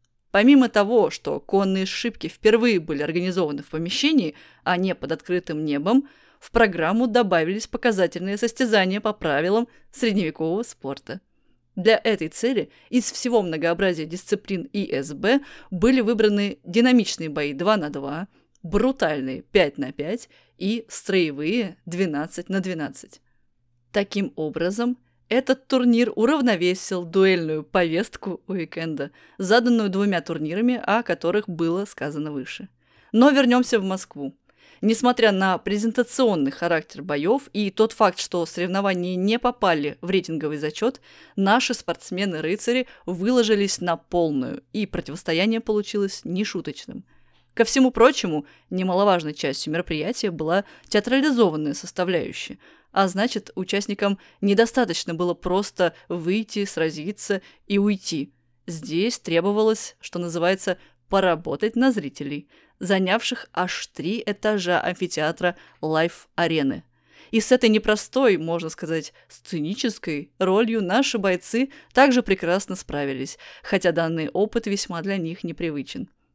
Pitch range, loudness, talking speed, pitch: 165-225 Hz, -23 LUFS, 115 wpm, 190 Hz